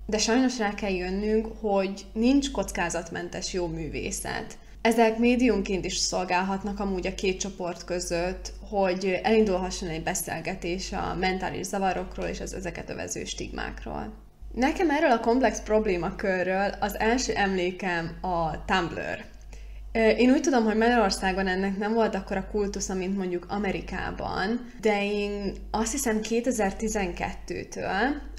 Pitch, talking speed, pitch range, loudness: 200 Hz, 125 wpm, 185-220 Hz, -27 LUFS